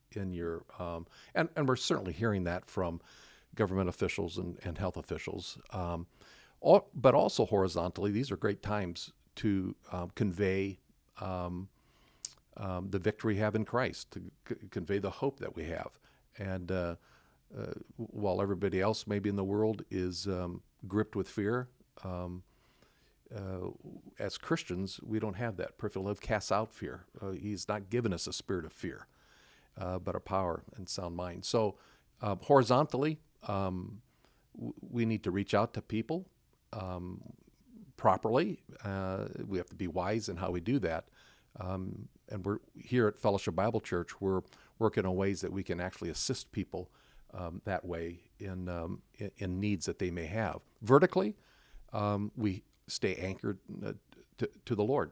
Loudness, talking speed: -35 LUFS, 165 wpm